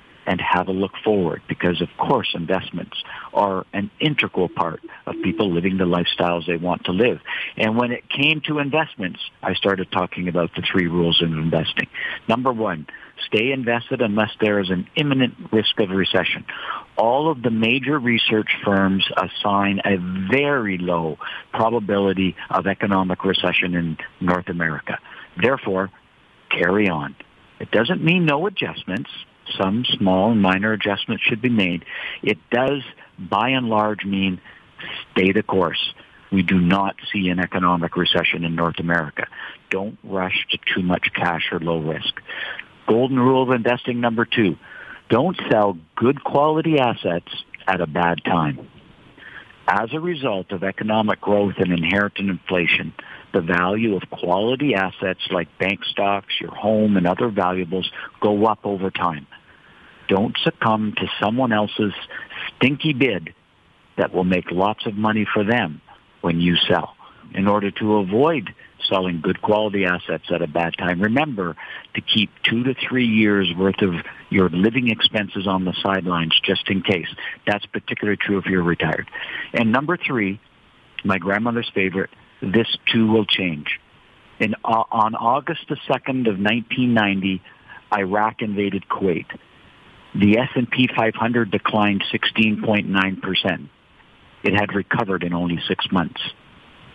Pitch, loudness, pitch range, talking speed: 100 Hz, -20 LUFS, 90-115 Hz, 150 wpm